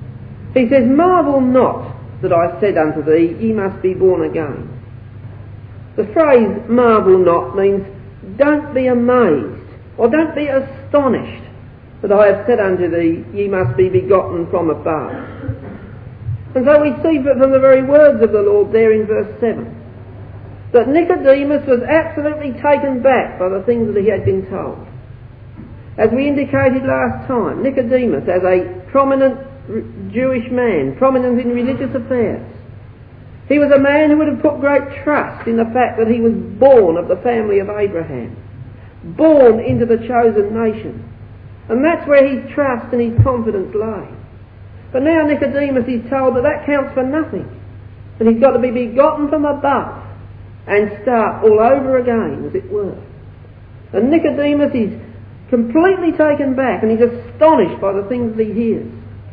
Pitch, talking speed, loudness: 230 Hz, 160 wpm, -14 LUFS